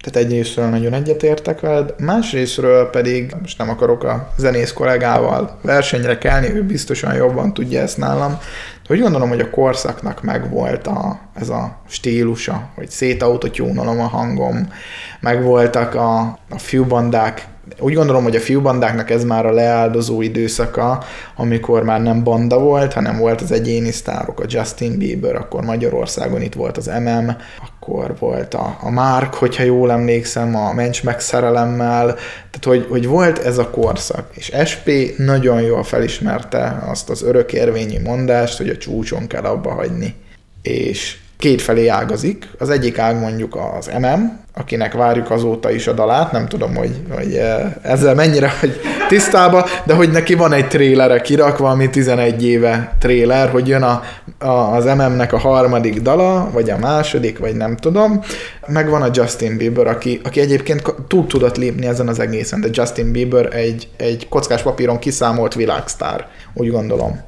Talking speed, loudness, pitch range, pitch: 160 wpm, -16 LUFS, 115-135 Hz, 120 Hz